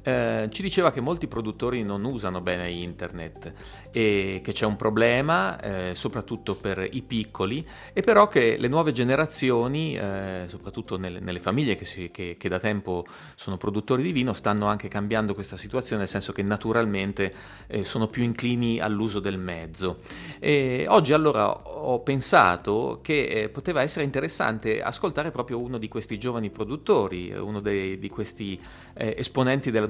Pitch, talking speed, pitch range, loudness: 110 Hz, 165 wpm, 95-125 Hz, -26 LUFS